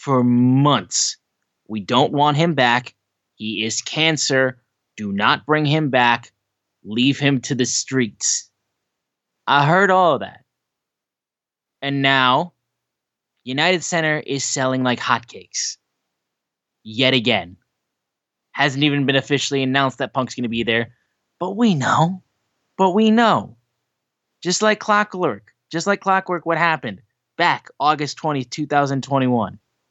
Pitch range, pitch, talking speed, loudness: 125-160 Hz, 140 Hz, 130 wpm, -18 LUFS